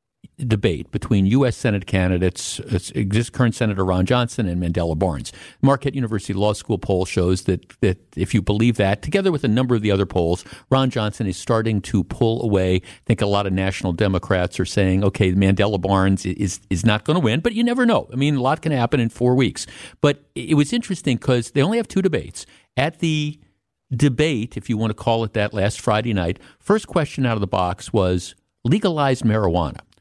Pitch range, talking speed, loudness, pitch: 95-130 Hz, 210 wpm, -20 LUFS, 110 Hz